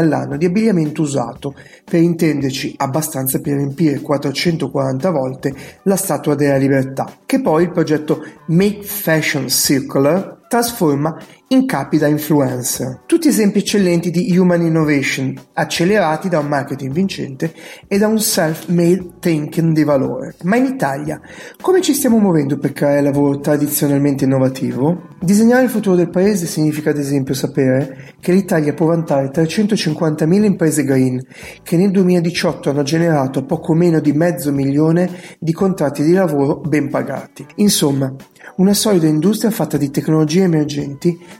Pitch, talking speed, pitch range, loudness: 160 Hz, 140 wpm, 145-180 Hz, -16 LUFS